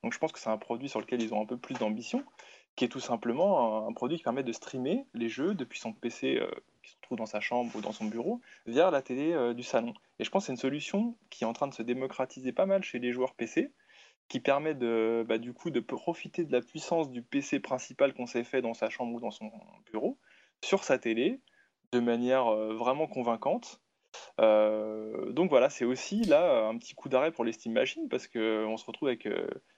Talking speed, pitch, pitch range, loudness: 240 wpm, 125 Hz, 115-160 Hz, -32 LUFS